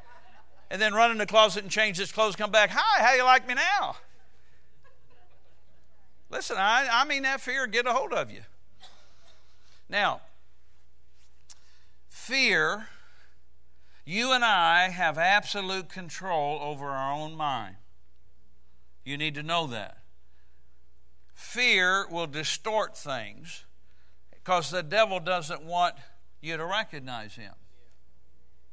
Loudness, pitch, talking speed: -26 LUFS, 135 Hz, 125 wpm